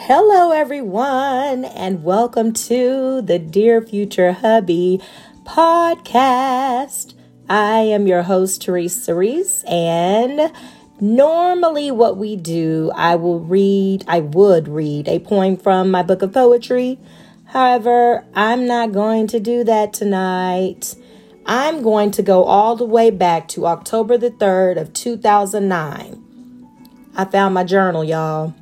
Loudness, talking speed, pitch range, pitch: -16 LUFS, 130 wpm, 185-245 Hz, 210 Hz